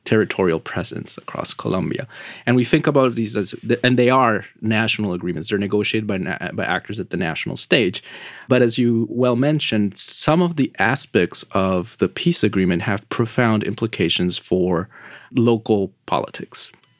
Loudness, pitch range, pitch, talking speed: -20 LUFS, 100-125 Hz, 110 Hz, 160 wpm